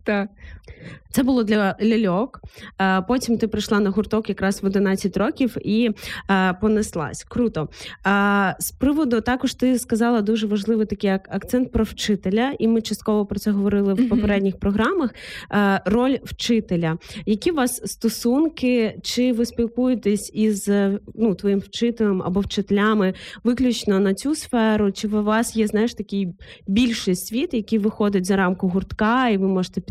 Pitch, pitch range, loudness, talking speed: 215 Hz, 195-235 Hz, -21 LUFS, 145 wpm